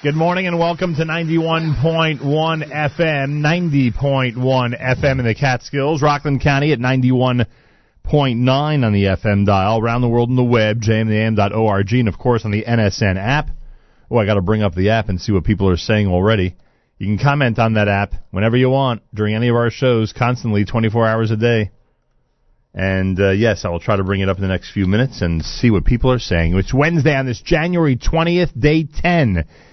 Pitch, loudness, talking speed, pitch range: 120 Hz, -17 LUFS, 195 wpm, 105-140 Hz